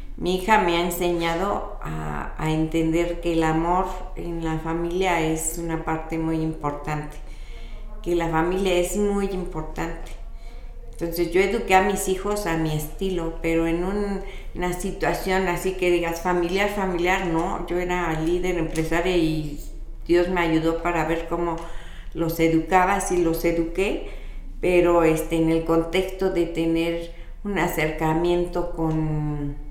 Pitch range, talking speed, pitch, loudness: 160-180 Hz, 145 wpm, 170 Hz, -24 LUFS